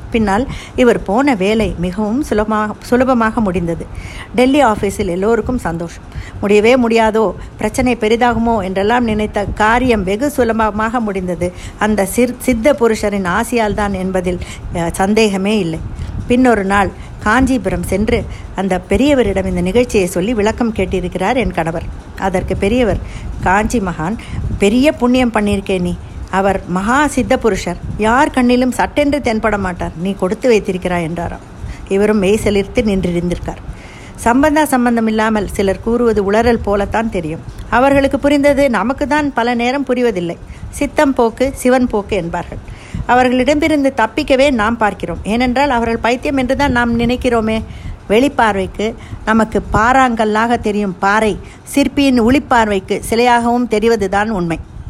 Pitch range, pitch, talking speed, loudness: 195-245 Hz, 220 Hz, 115 wpm, -14 LUFS